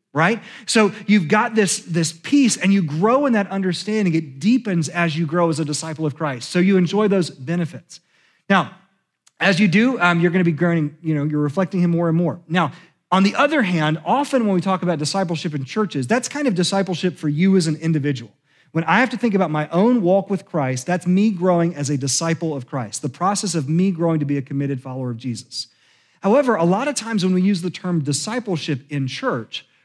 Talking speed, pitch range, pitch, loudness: 225 wpm, 155-195 Hz, 175 Hz, -19 LUFS